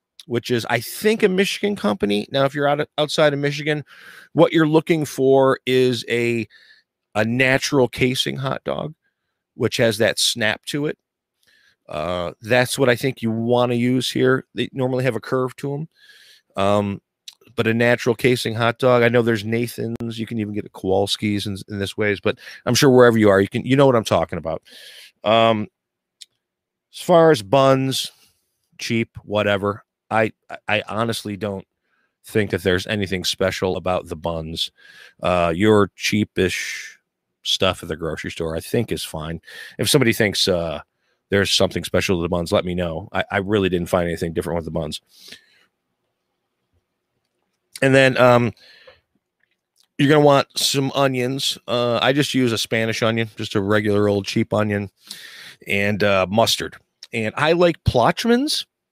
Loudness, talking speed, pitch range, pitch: -19 LUFS, 170 wpm, 100-130 Hz, 115 Hz